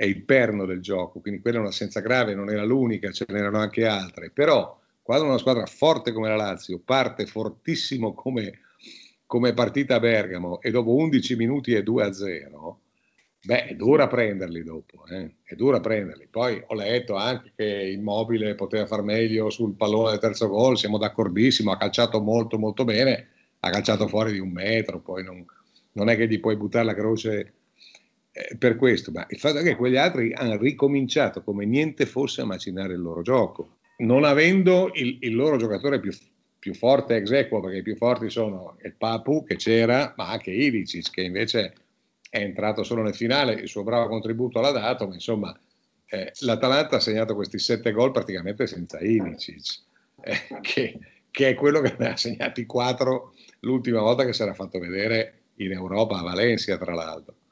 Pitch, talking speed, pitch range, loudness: 110 Hz, 185 wpm, 100-125 Hz, -24 LUFS